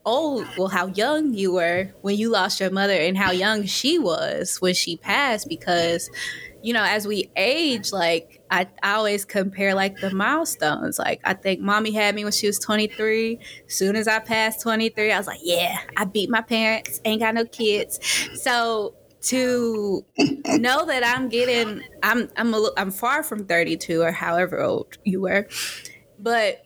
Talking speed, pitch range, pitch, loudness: 180 wpm, 190-230 Hz, 210 Hz, -22 LUFS